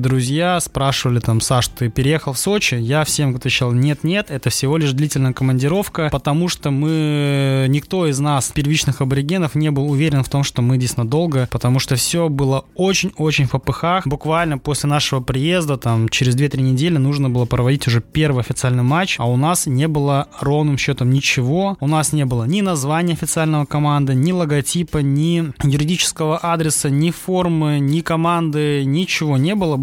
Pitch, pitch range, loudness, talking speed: 145 Hz, 135-160 Hz, -17 LUFS, 170 wpm